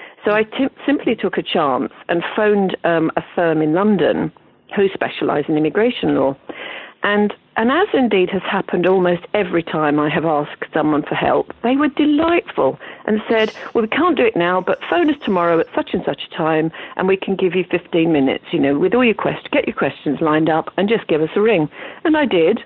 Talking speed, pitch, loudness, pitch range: 215 wpm, 185 Hz, -17 LUFS, 160-225 Hz